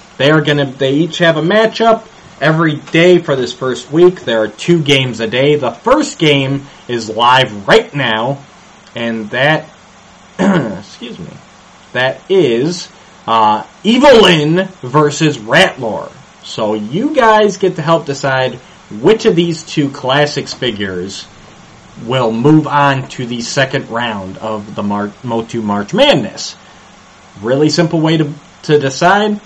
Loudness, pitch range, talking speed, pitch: -12 LUFS, 120-170 Hz, 140 wpm, 140 Hz